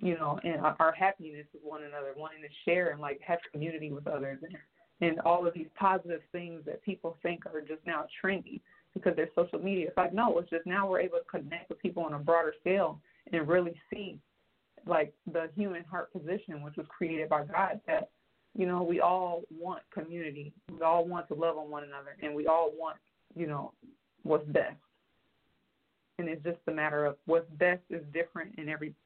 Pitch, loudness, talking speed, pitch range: 165 Hz, -33 LUFS, 200 wpm, 155-180 Hz